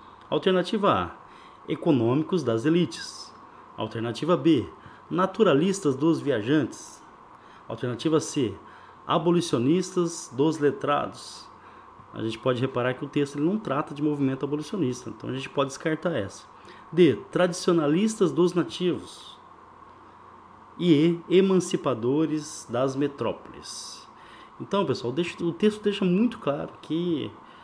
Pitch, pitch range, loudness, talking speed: 165 Hz, 140-180 Hz, -26 LUFS, 110 wpm